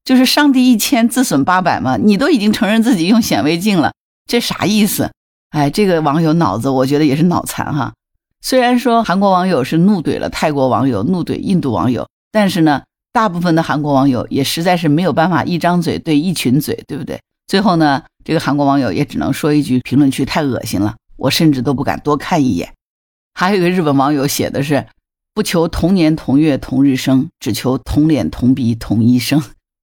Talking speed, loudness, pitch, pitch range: 310 characters per minute, -14 LUFS, 155 Hz, 135-190 Hz